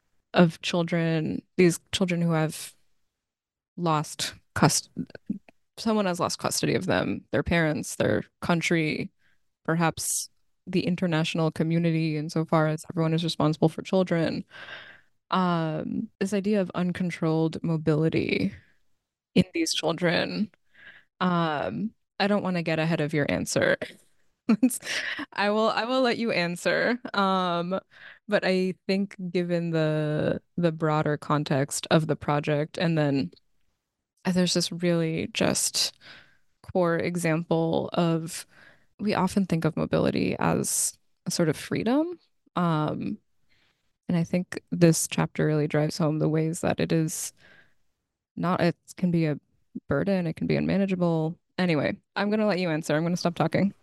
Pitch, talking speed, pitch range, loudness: 170 Hz, 135 wpm, 160-185 Hz, -26 LUFS